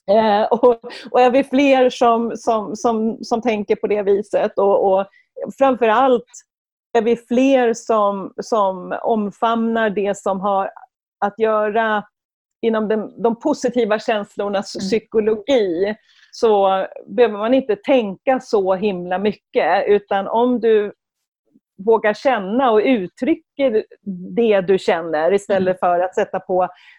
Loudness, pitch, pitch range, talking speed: -18 LUFS, 220 Hz, 200-240 Hz, 125 wpm